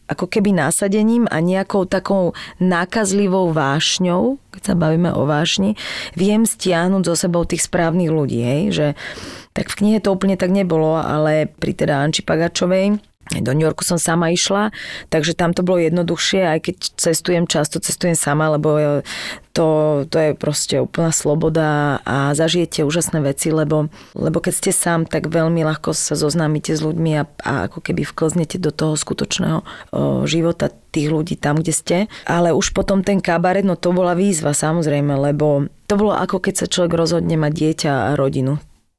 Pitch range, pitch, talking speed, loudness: 155-185 Hz, 165 Hz, 170 wpm, -18 LUFS